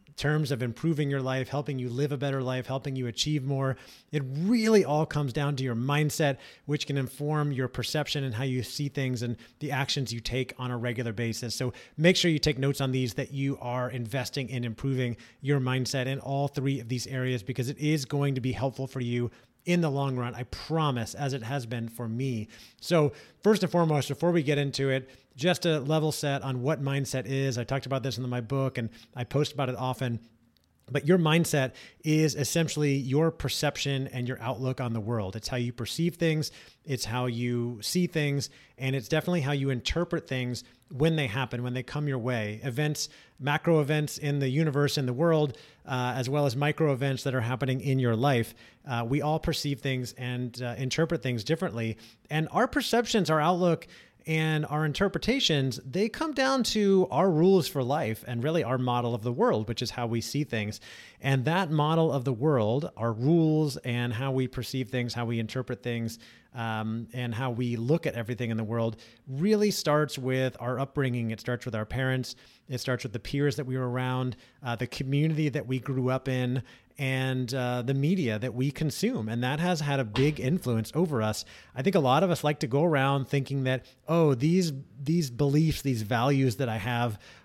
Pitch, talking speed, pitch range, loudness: 135 Hz, 210 wpm, 125-150 Hz, -29 LUFS